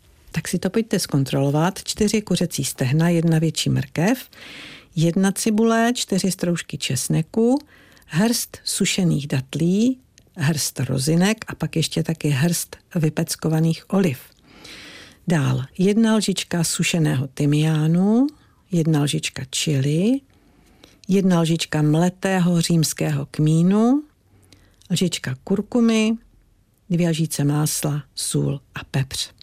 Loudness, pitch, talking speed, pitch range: -21 LUFS, 165 Hz, 100 wpm, 145-190 Hz